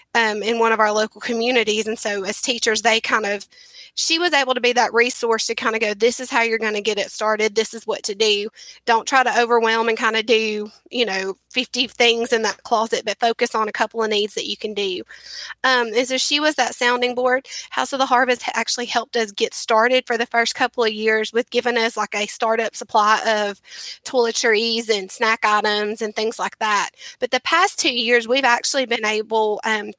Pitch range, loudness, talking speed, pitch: 220-245 Hz, -19 LUFS, 230 wpm, 230 Hz